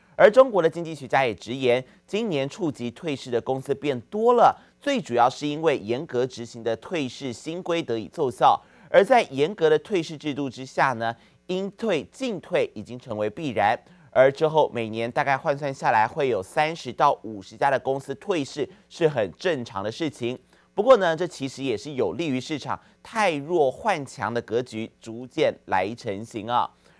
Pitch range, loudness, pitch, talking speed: 120-160 Hz, -24 LUFS, 135 Hz, 270 characters per minute